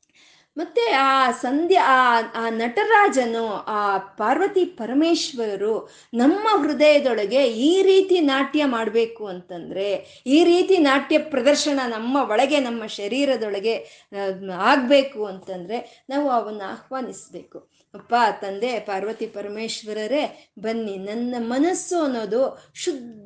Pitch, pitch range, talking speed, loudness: 245 Hz, 215-290 Hz, 95 wpm, -21 LUFS